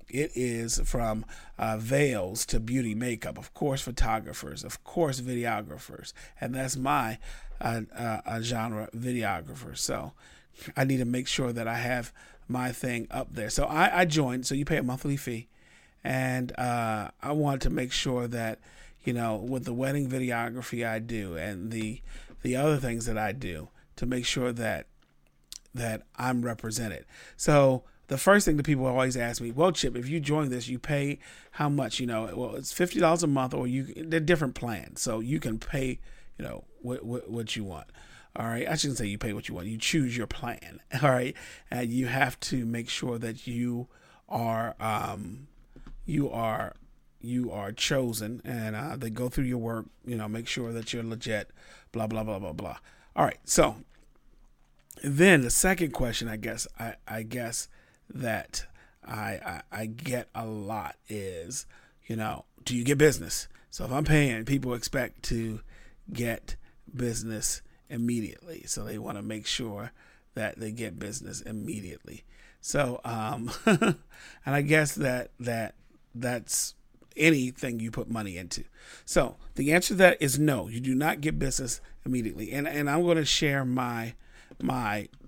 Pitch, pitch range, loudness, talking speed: 120 Hz, 110-135 Hz, -29 LUFS, 175 wpm